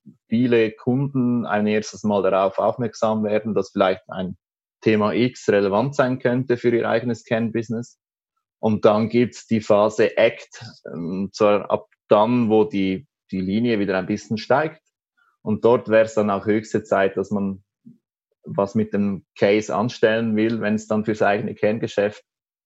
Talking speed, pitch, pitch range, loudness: 160 wpm, 110 Hz, 105-120 Hz, -21 LUFS